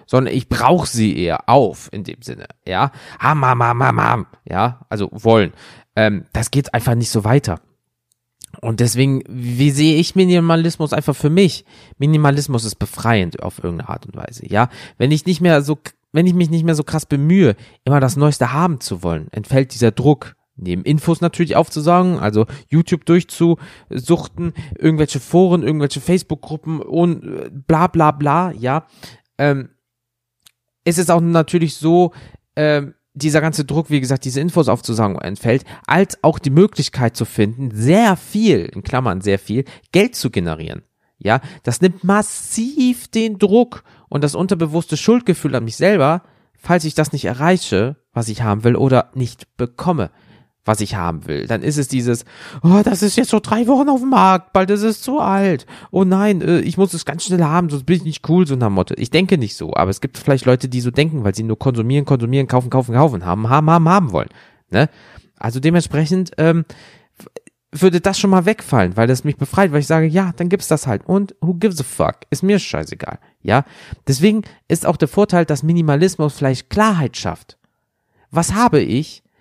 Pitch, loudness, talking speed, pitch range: 150 Hz, -16 LUFS, 185 wpm, 120-175 Hz